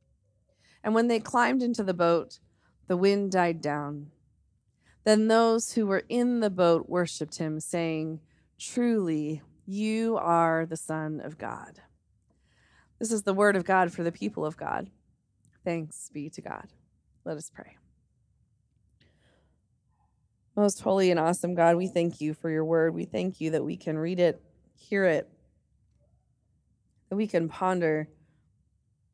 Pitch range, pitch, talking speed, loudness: 150-195 Hz, 170 Hz, 145 wpm, -27 LUFS